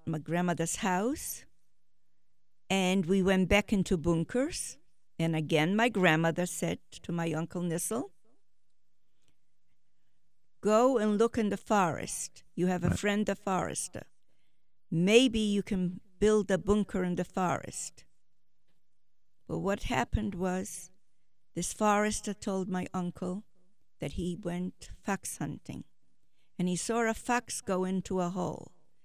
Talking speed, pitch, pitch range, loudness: 130 wpm, 185 Hz, 175-205 Hz, -31 LUFS